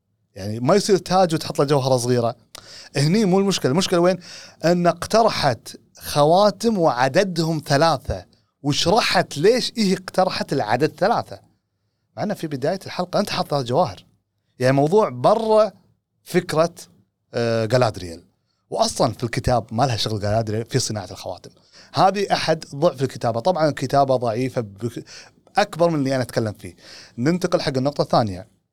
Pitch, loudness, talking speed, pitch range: 145 Hz, -20 LUFS, 130 wpm, 115-180 Hz